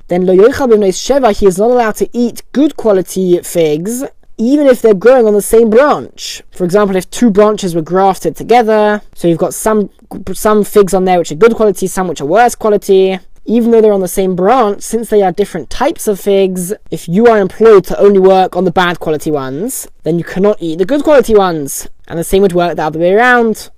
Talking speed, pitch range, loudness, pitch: 220 wpm, 180-220 Hz, -10 LUFS, 195 Hz